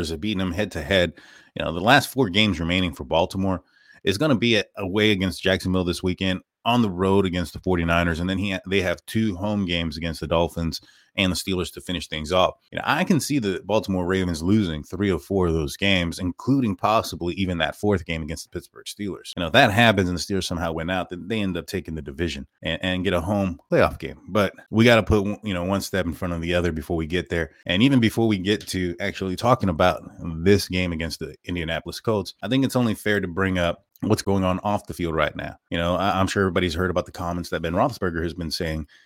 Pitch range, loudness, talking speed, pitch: 85-100 Hz, -23 LUFS, 250 wpm, 95 Hz